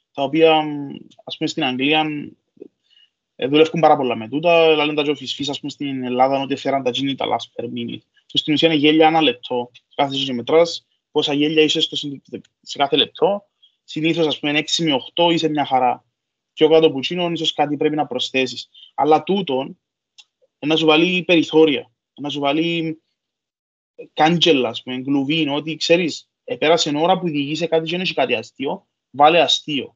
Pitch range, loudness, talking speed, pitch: 140-160 Hz, -18 LUFS, 175 wpm, 155 Hz